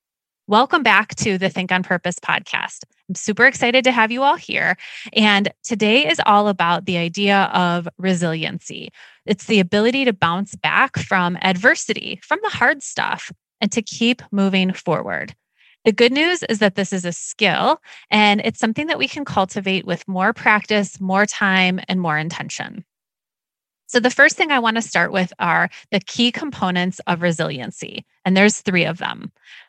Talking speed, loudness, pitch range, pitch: 175 wpm, -18 LUFS, 185-235 Hz, 205 Hz